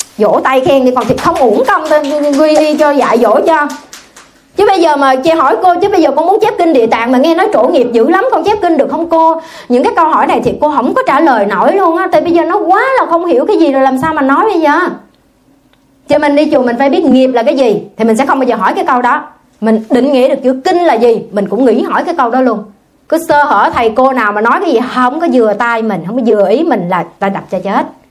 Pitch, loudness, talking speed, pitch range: 280 Hz, -10 LUFS, 295 wpm, 245-325 Hz